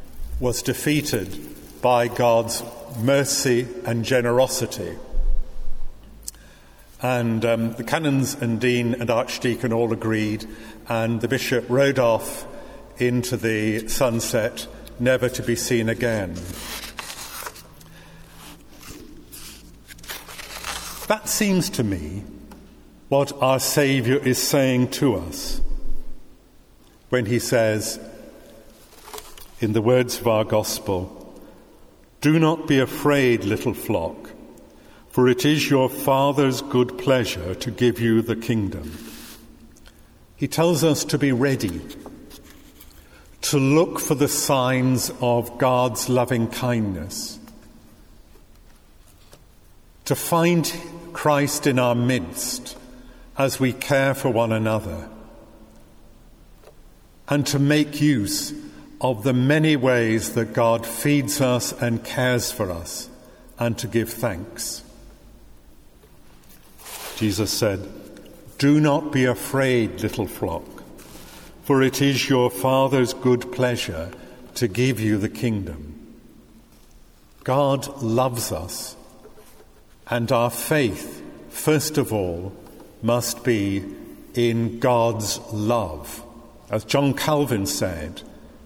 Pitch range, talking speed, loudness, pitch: 110-135 Hz, 105 wpm, -22 LUFS, 120 Hz